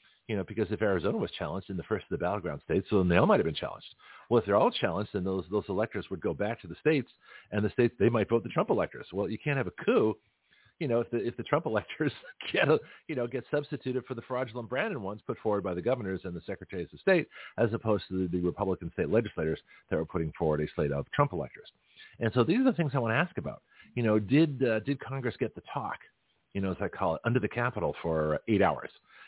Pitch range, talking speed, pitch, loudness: 95-125 Hz, 265 wpm, 110 Hz, -31 LUFS